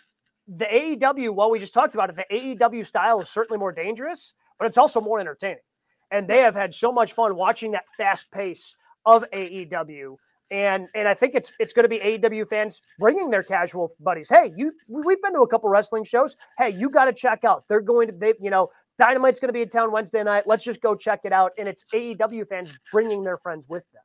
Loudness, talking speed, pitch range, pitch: -22 LUFS, 230 wpm, 195-235 Hz, 220 Hz